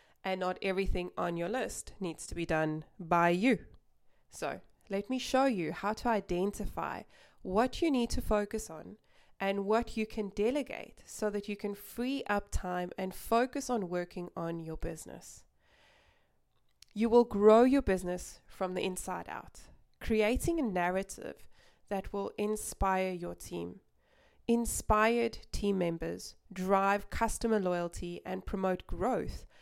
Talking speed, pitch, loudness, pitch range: 145 wpm, 200 Hz, -33 LUFS, 180-225 Hz